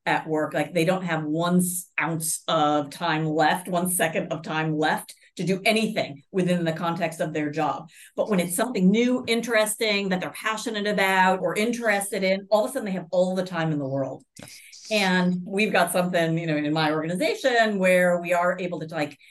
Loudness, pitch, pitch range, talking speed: -24 LUFS, 180 Hz, 160-205 Hz, 200 wpm